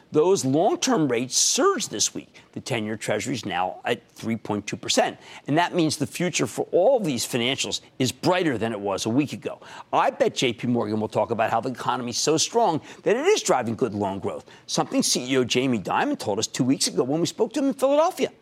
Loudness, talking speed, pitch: -23 LUFS, 220 wpm, 145 Hz